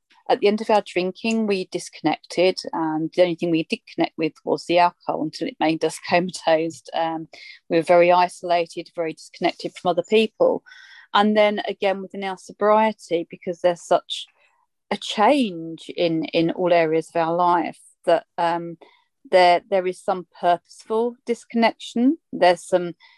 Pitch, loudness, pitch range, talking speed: 180 Hz, -22 LUFS, 170-215 Hz, 160 wpm